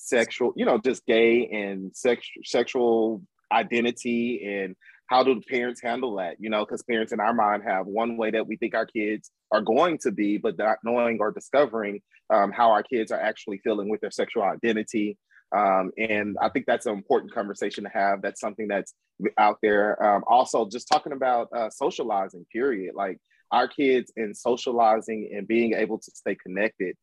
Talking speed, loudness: 190 wpm, -25 LUFS